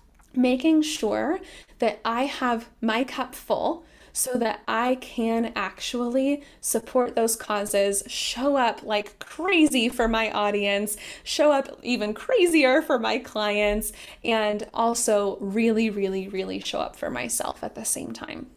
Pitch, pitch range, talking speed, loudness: 230 Hz, 210-265 Hz, 140 wpm, -25 LUFS